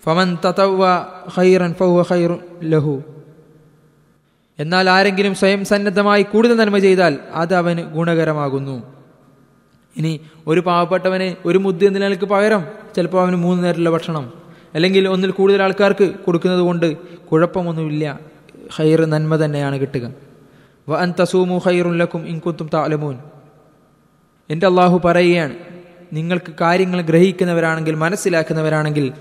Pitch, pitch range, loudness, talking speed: 175 Hz, 155-185 Hz, -16 LUFS, 85 wpm